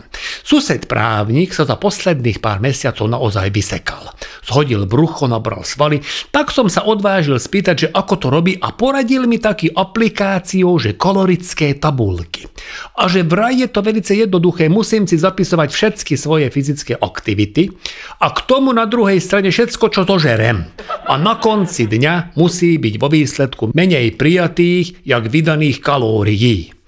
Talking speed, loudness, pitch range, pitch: 145 wpm, -14 LUFS, 125-195 Hz, 165 Hz